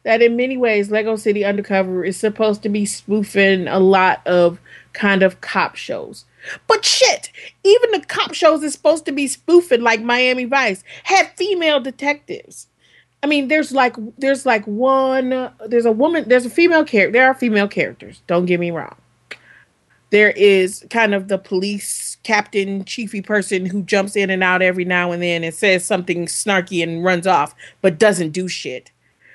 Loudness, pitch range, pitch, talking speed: -16 LUFS, 190-265 Hz, 210 Hz, 180 wpm